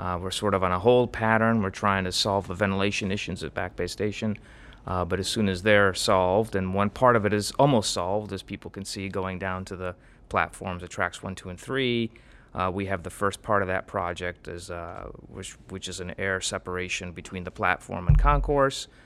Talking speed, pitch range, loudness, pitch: 225 wpm, 90-105 Hz, -26 LUFS, 95 Hz